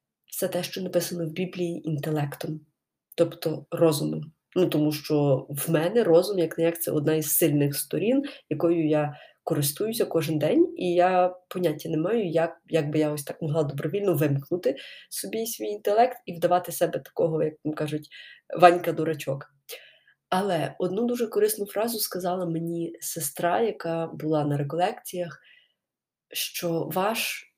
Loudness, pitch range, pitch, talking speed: -26 LUFS, 155-180 Hz, 165 Hz, 150 wpm